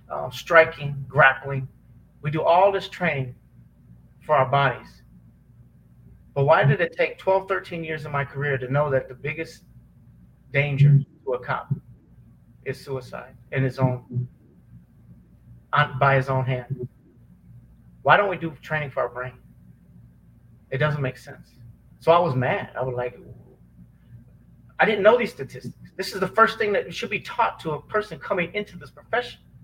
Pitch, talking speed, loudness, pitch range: 135 Hz, 165 wpm, -23 LUFS, 120-160 Hz